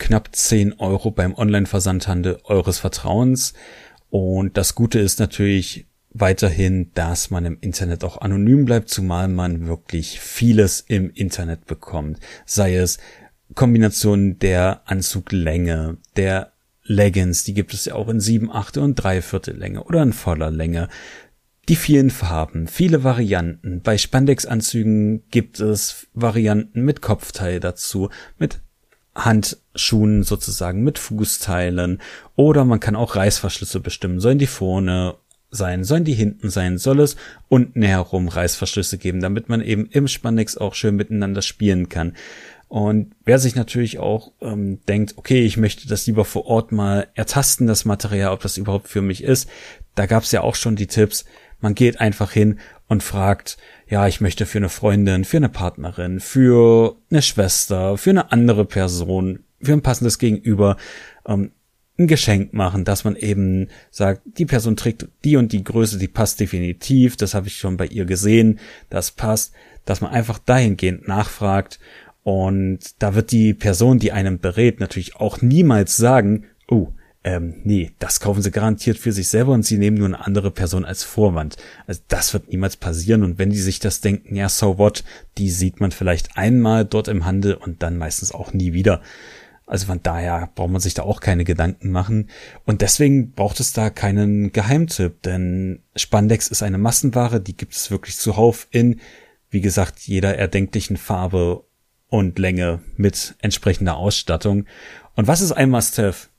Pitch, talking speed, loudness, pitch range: 100 Hz, 165 wpm, -19 LUFS, 95-115 Hz